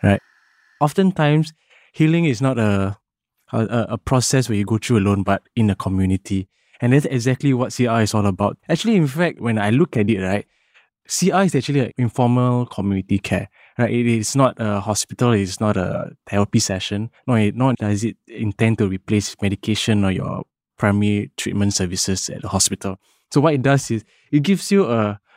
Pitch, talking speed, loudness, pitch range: 110 Hz, 185 wpm, -19 LUFS, 100-130 Hz